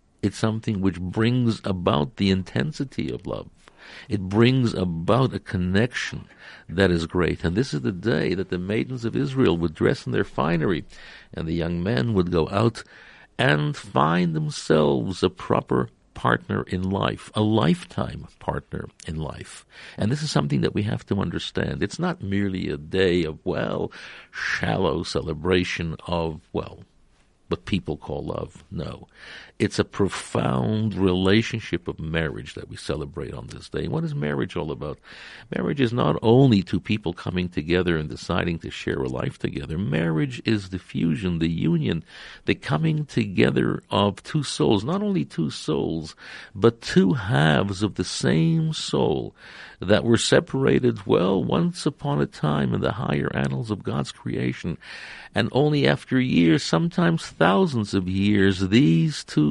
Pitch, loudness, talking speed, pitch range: 95 Hz, -24 LUFS, 160 wpm, 85-115 Hz